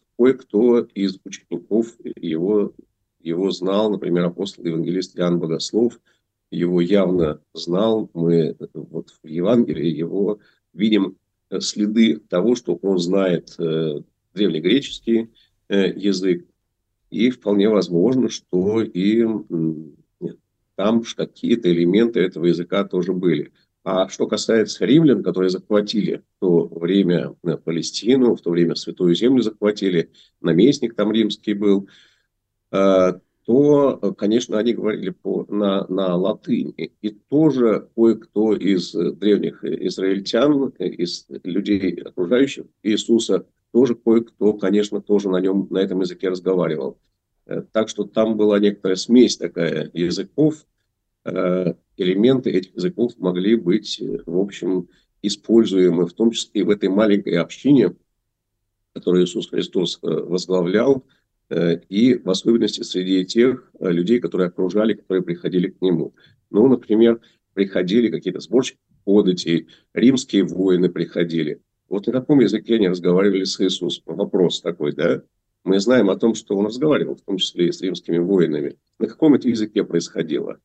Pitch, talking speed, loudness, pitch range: 100 Hz, 125 wpm, -20 LUFS, 90-110 Hz